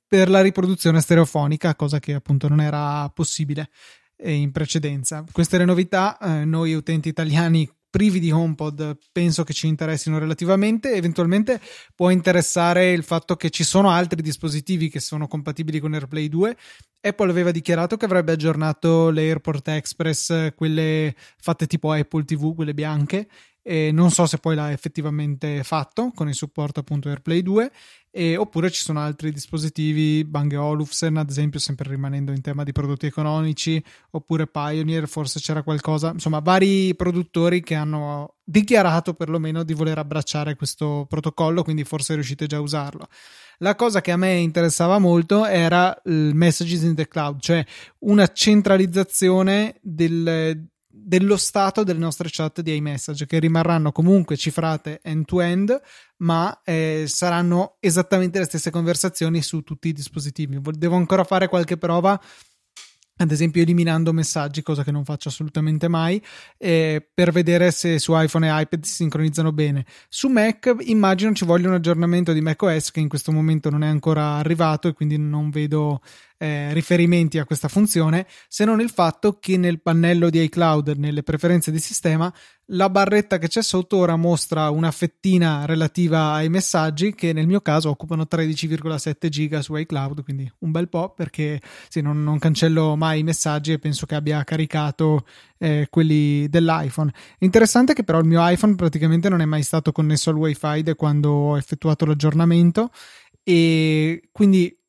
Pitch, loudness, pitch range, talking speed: 160 Hz, -20 LUFS, 155-175 Hz, 160 wpm